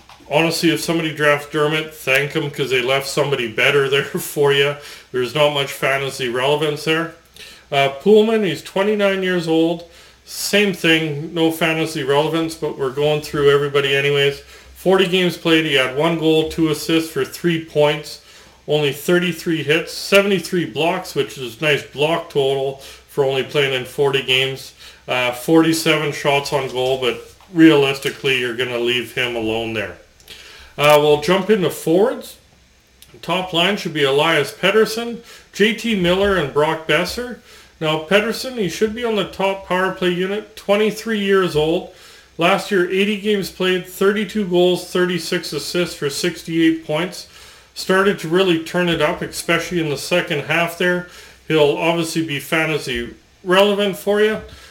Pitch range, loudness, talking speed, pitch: 145-185 Hz, -18 LUFS, 155 wpm, 160 Hz